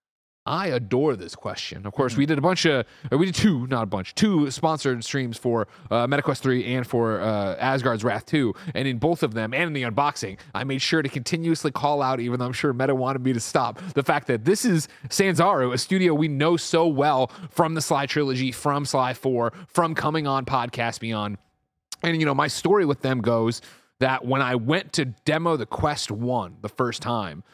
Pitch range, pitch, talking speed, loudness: 120-155 Hz, 135 Hz, 215 wpm, -24 LUFS